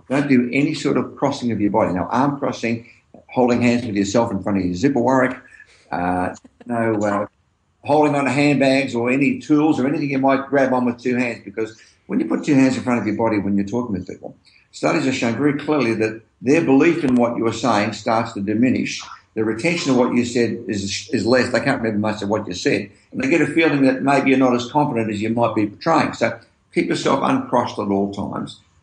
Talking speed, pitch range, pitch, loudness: 235 wpm, 105-135 Hz, 120 Hz, -19 LUFS